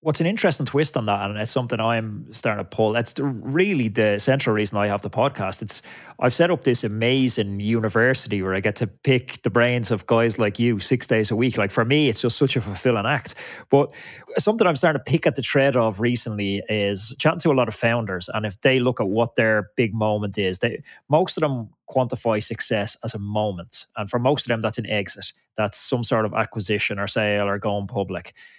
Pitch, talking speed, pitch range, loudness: 115 Hz, 230 wpm, 105-130 Hz, -22 LUFS